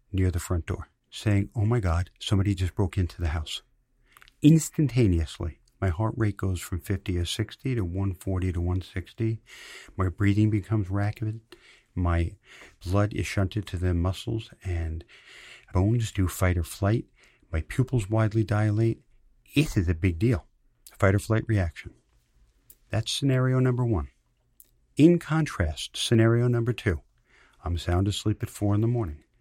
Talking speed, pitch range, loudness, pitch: 150 wpm, 90-115 Hz, -27 LUFS, 100 Hz